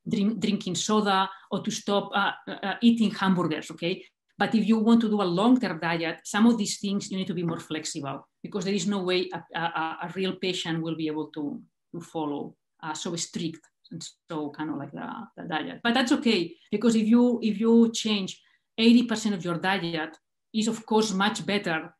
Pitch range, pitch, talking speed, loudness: 170-220 Hz, 195 Hz, 205 wpm, -26 LUFS